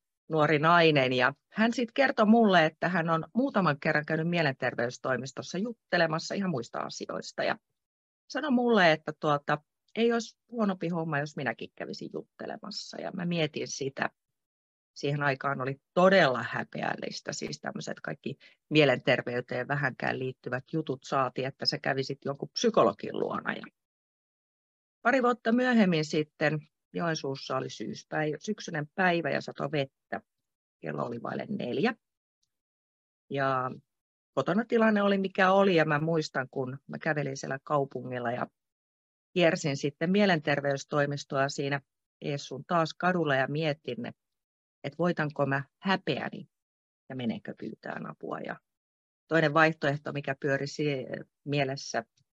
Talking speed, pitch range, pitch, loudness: 125 wpm, 135-175 Hz, 150 Hz, -29 LUFS